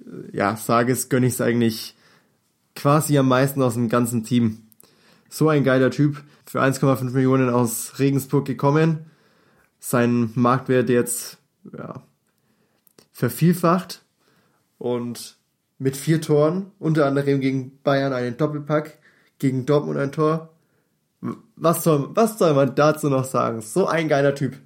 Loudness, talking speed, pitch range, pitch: -21 LUFS, 135 wpm, 120-150 Hz, 135 Hz